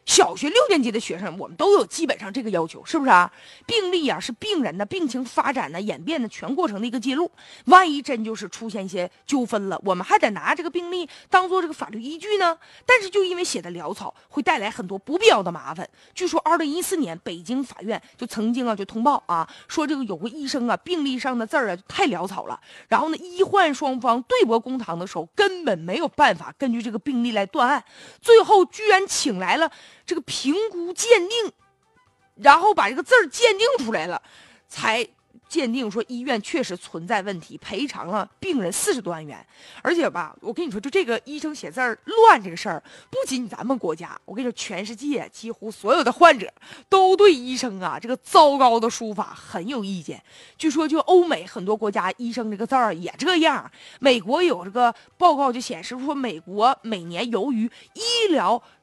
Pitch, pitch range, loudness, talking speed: 265 Hz, 225-345 Hz, -21 LUFS, 310 characters per minute